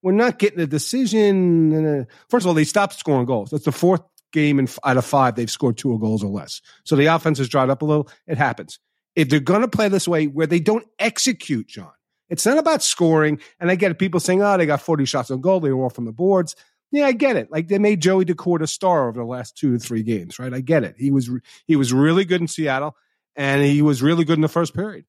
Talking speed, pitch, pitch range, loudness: 260 wpm, 155 Hz, 135-185 Hz, -19 LUFS